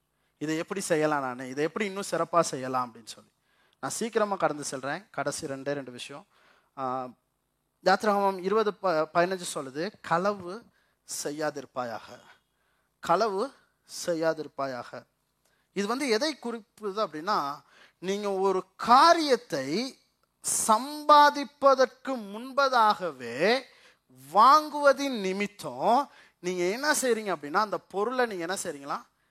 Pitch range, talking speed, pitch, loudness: 150-220 Hz, 100 wpm, 190 Hz, -27 LUFS